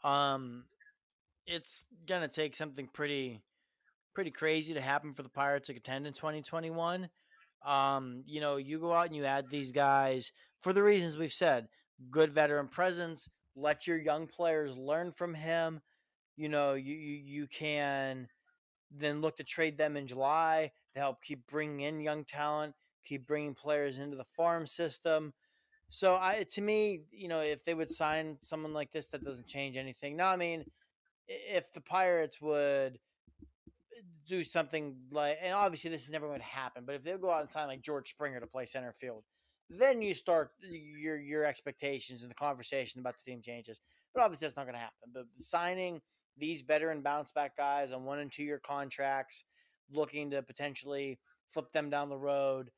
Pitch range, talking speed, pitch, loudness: 140-165 Hz, 185 wpm, 150 Hz, -35 LUFS